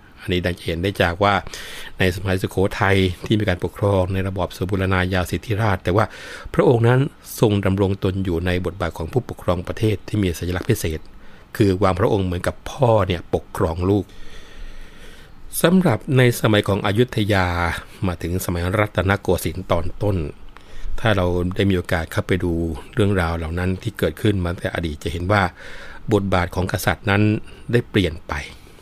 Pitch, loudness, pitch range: 95 Hz, -21 LUFS, 90-105 Hz